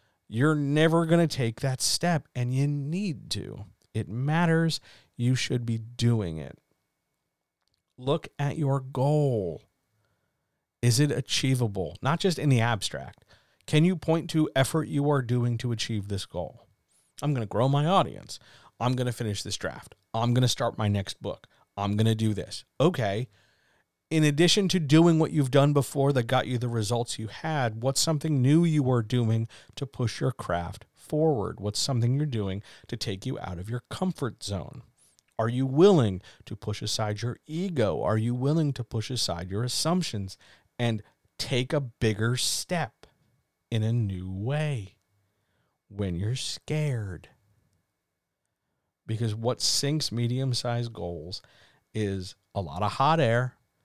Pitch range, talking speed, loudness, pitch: 105-145 Hz, 160 wpm, -27 LUFS, 120 Hz